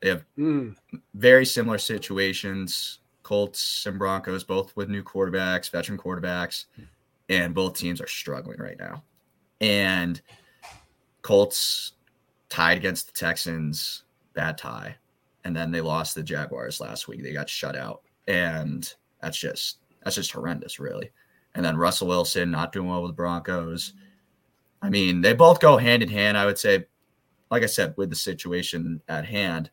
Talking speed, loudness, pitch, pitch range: 155 wpm, -24 LUFS, 95 Hz, 85-100 Hz